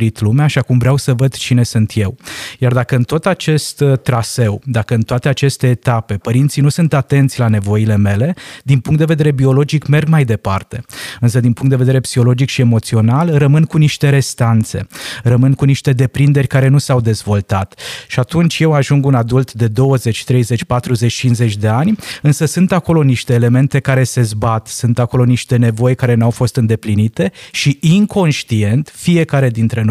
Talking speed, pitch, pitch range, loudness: 180 wpm, 130 Hz, 115-140 Hz, -13 LUFS